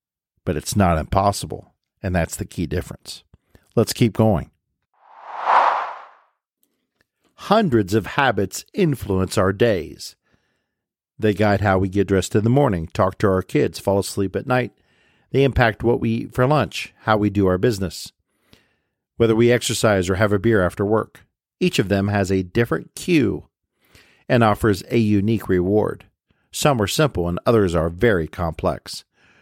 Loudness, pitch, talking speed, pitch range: -20 LUFS, 105 Hz, 155 wpm, 95-115 Hz